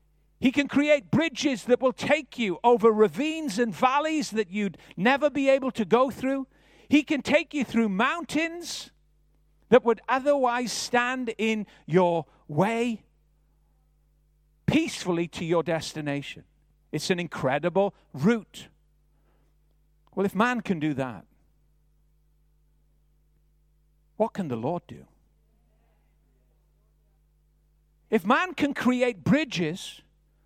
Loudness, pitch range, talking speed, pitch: -26 LUFS, 150-250 Hz, 110 wpm, 190 Hz